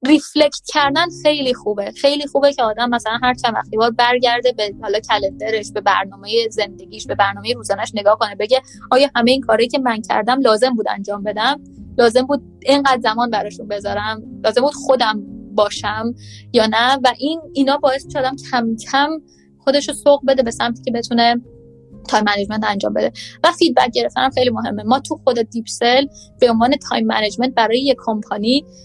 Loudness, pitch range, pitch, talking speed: -17 LUFS, 215-270 Hz, 240 Hz, 175 wpm